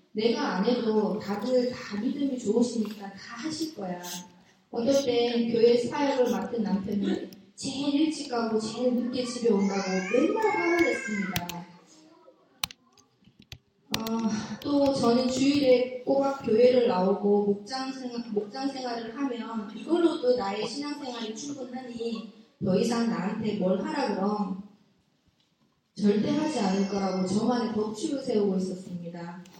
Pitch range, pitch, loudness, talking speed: 200-255 Hz, 230 Hz, -28 LUFS, 265 characters per minute